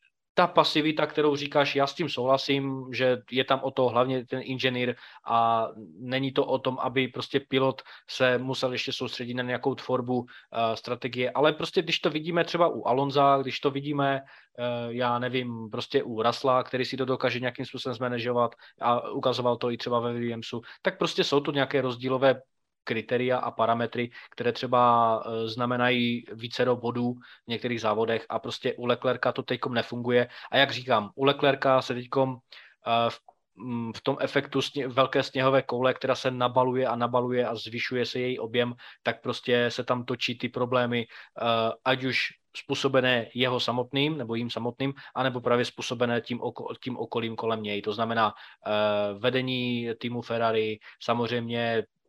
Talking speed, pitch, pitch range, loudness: 170 wpm, 125 Hz, 120-135 Hz, -27 LUFS